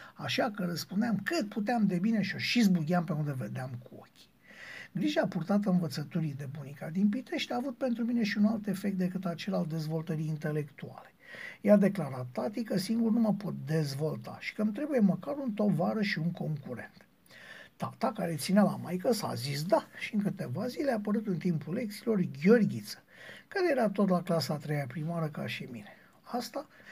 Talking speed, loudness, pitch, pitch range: 190 wpm, -31 LUFS, 195 Hz, 165-225 Hz